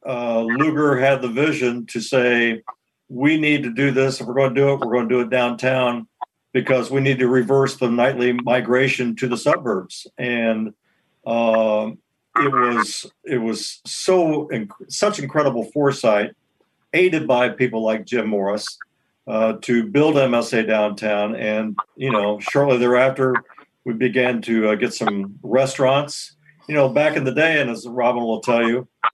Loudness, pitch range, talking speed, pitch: -19 LUFS, 115-135 Hz, 165 wpm, 125 Hz